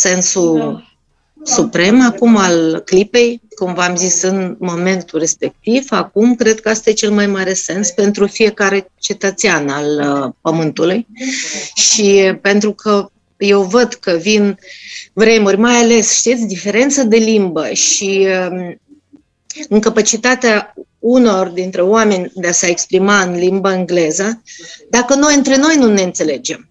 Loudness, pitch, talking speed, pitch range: -12 LUFS, 205 Hz, 130 wpm, 185-230 Hz